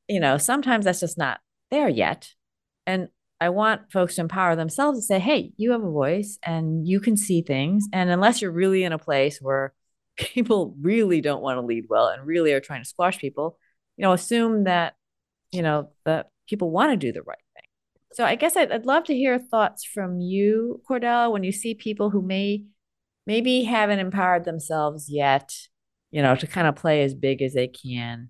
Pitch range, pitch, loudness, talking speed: 150-215 Hz, 180 Hz, -23 LUFS, 205 wpm